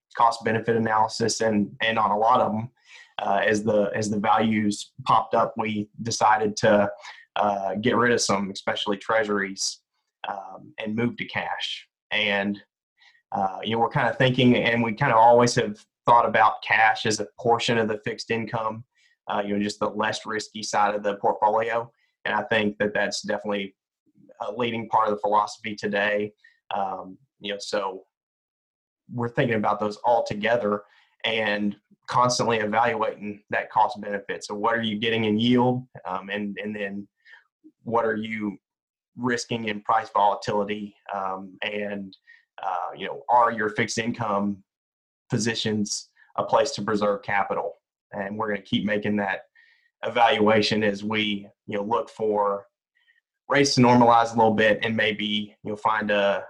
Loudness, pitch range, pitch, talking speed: -24 LUFS, 105-115 Hz, 110 Hz, 160 wpm